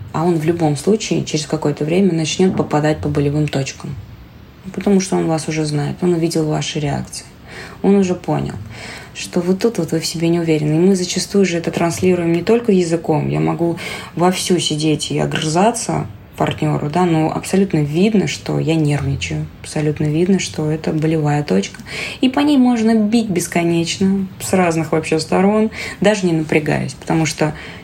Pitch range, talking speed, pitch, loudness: 155-185 Hz, 170 wpm, 165 Hz, -17 LUFS